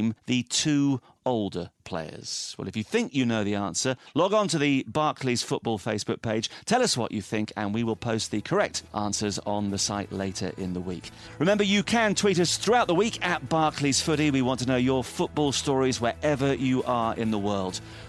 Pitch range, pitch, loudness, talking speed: 105-140 Hz, 115 Hz, -26 LUFS, 210 wpm